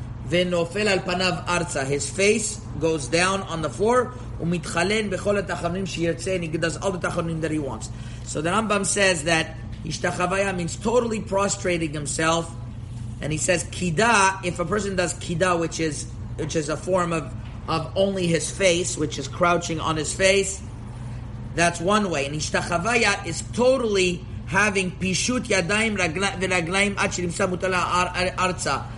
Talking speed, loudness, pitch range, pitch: 145 wpm, -23 LUFS, 150-190 Hz, 175 Hz